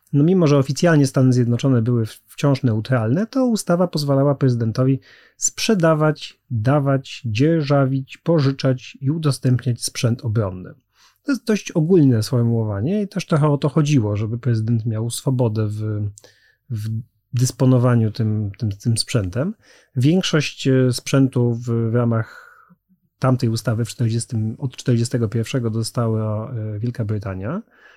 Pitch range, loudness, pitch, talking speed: 115-145 Hz, -20 LUFS, 125 Hz, 120 wpm